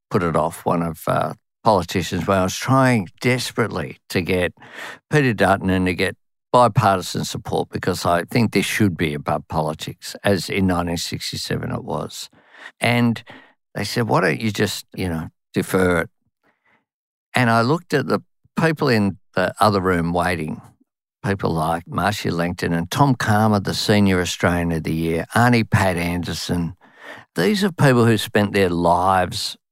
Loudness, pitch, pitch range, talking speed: -20 LUFS, 95 Hz, 85-115 Hz, 155 wpm